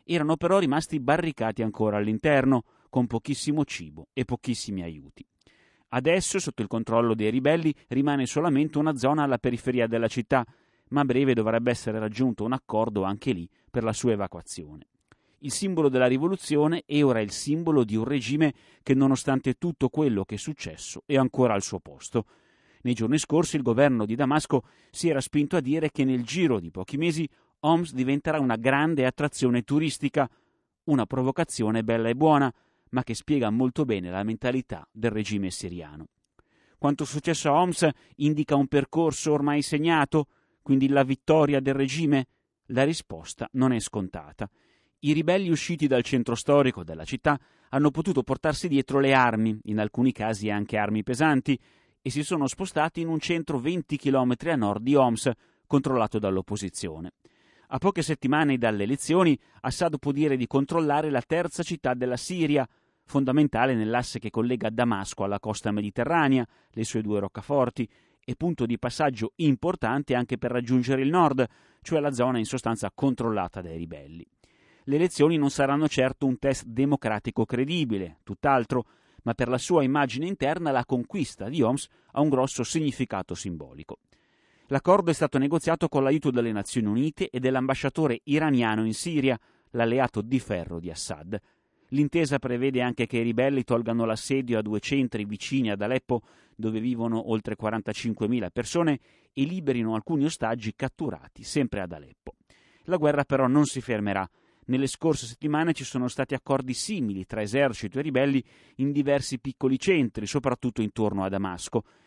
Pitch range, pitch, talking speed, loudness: 115-150 Hz, 130 Hz, 160 wpm, -26 LUFS